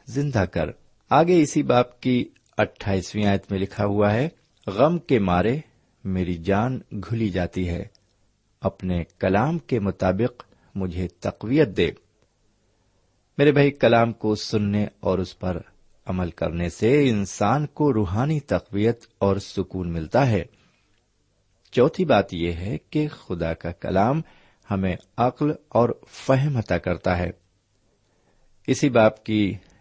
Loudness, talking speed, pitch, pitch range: -23 LUFS, 130 wpm, 105 Hz, 95-120 Hz